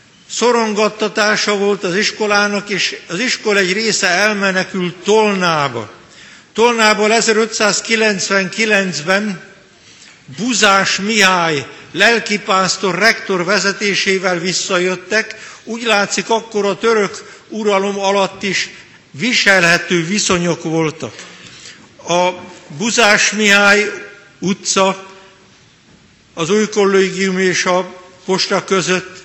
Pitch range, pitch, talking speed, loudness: 185-210 Hz, 195 Hz, 85 wpm, -14 LUFS